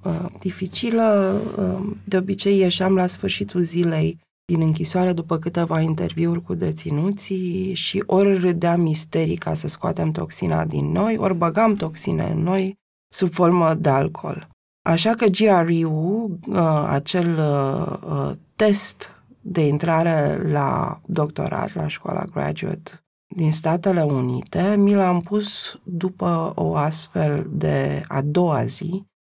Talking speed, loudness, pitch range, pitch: 120 wpm, -21 LUFS, 160-190 Hz, 175 Hz